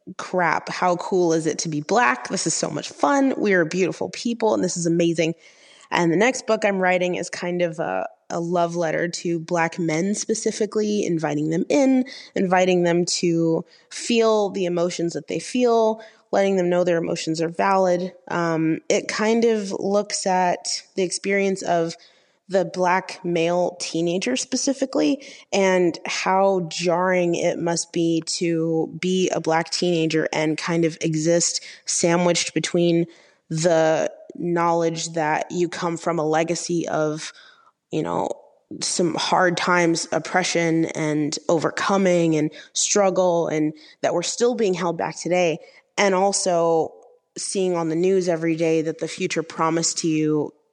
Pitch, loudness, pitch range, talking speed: 175 Hz, -22 LUFS, 165-190 Hz, 155 wpm